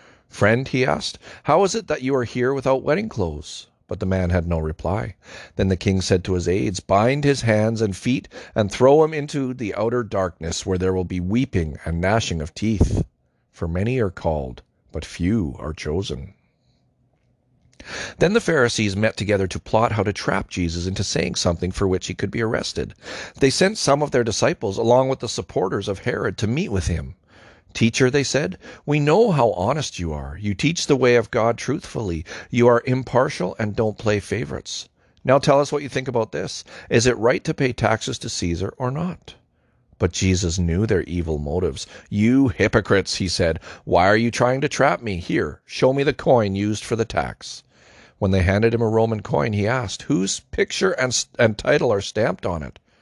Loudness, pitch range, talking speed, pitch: -21 LUFS, 95-130 Hz, 200 wpm, 110 Hz